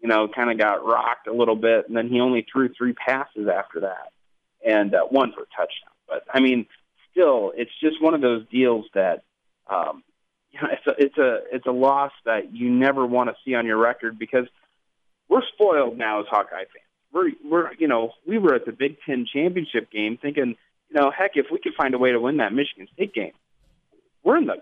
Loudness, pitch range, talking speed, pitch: -22 LUFS, 115-140 Hz, 225 wpm, 125 Hz